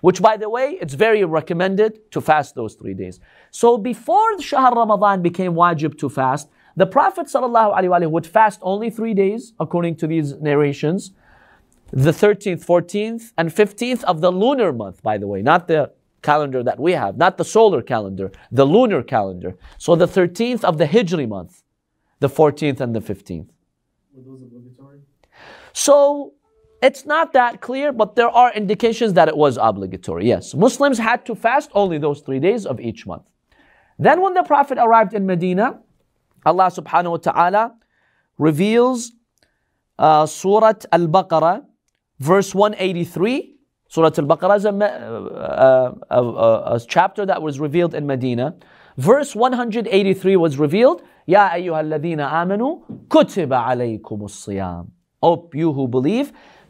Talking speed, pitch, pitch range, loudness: 150 wpm, 180 Hz, 150-225 Hz, -17 LUFS